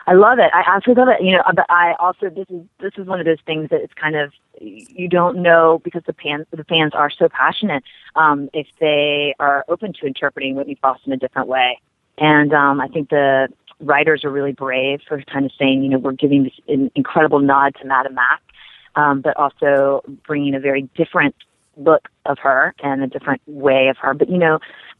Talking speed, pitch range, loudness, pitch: 220 wpm, 140-170 Hz, -16 LUFS, 145 Hz